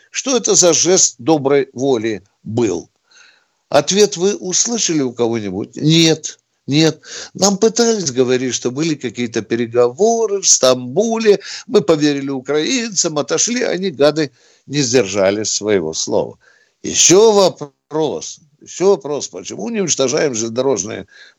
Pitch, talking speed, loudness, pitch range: 155 Hz, 115 wpm, -15 LUFS, 130-195 Hz